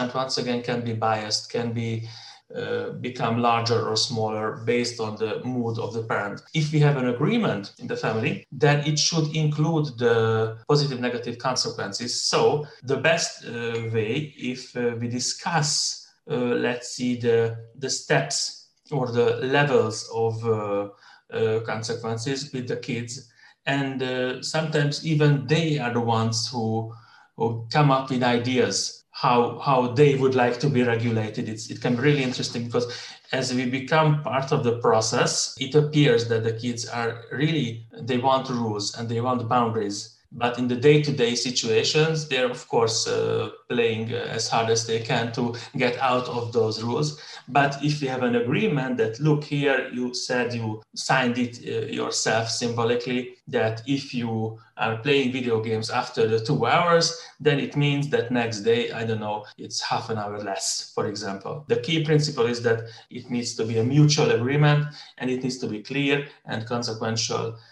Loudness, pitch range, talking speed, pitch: -24 LUFS, 115-145 Hz, 175 wpm, 125 Hz